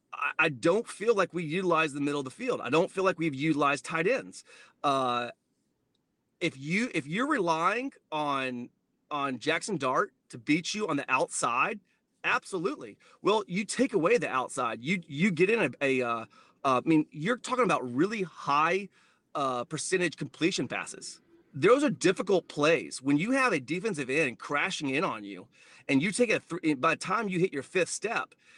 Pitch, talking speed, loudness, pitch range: 165 Hz, 185 wpm, -29 LUFS, 145-205 Hz